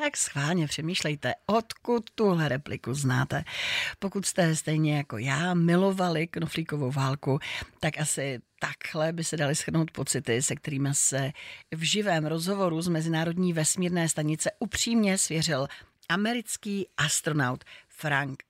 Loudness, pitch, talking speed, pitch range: -28 LUFS, 160 Hz, 125 wpm, 145-180 Hz